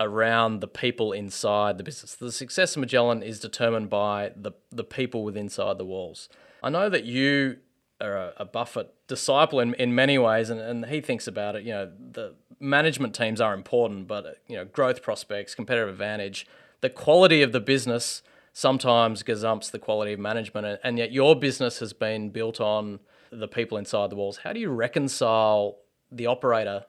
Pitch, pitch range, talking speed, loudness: 115 Hz, 105-125 Hz, 185 wpm, -25 LUFS